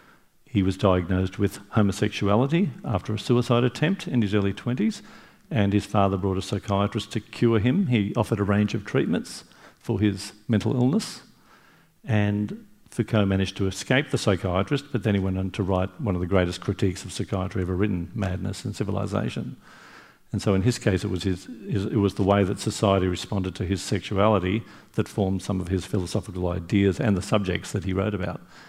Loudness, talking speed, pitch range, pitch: -25 LUFS, 190 wpm, 95-110 Hz, 100 Hz